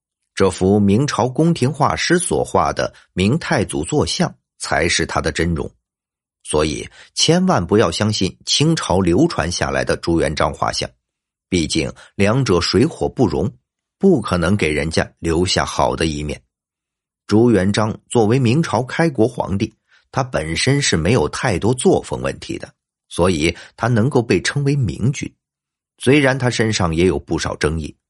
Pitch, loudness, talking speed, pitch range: 105 Hz, -18 LUFS, 230 characters per minute, 85-130 Hz